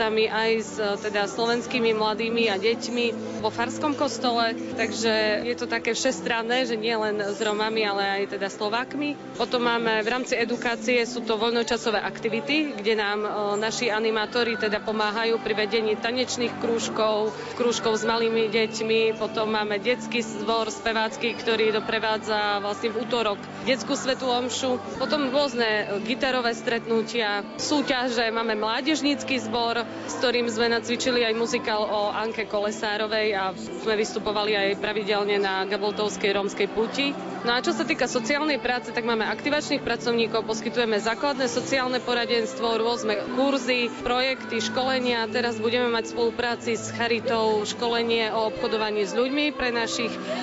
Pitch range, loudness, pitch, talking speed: 215-245 Hz, -25 LUFS, 230 Hz, 140 wpm